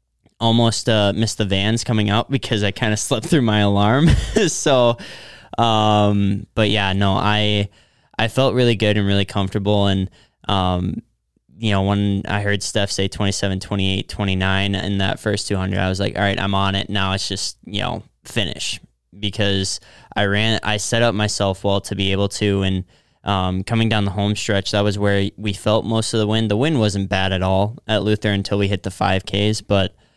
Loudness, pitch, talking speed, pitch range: -19 LUFS, 100 Hz, 200 wpm, 100-110 Hz